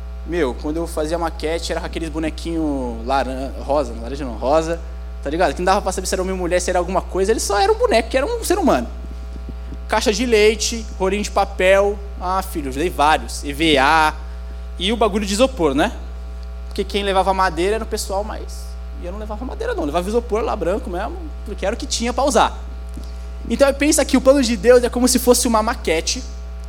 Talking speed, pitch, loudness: 215 wpm, 185 Hz, -19 LUFS